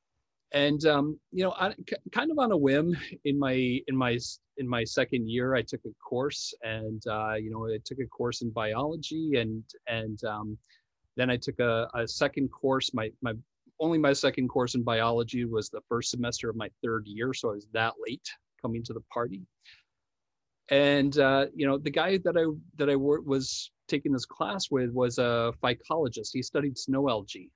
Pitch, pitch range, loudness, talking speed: 125 Hz, 115-140 Hz, -29 LUFS, 195 wpm